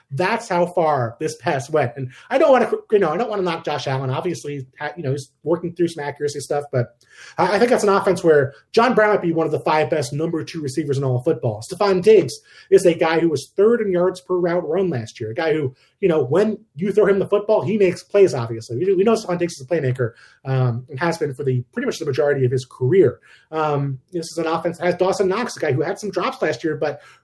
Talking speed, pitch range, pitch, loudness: 260 wpm, 140-185 Hz, 165 Hz, -20 LUFS